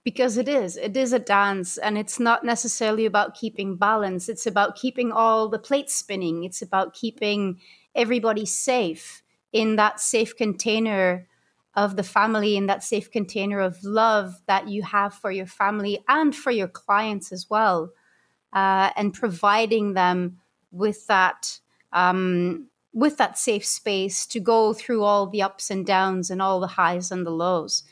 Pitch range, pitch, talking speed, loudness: 190-225 Hz, 205 Hz, 165 wpm, -23 LUFS